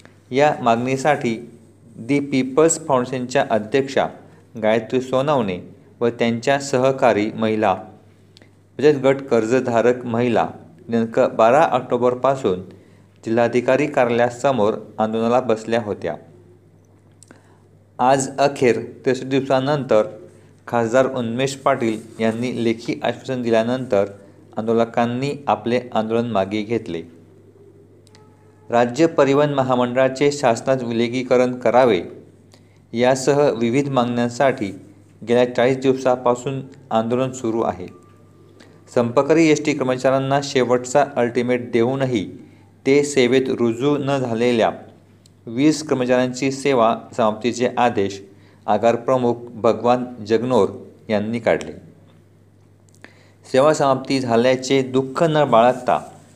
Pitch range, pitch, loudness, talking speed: 110-130 Hz, 120 Hz, -19 LUFS, 90 wpm